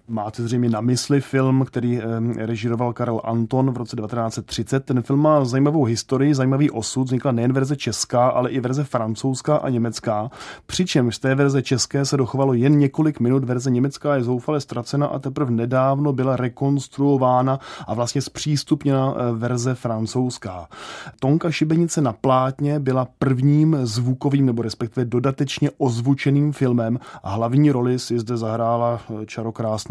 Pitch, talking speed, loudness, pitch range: 130 Hz, 145 wpm, -21 LUFS, 120-140 Hz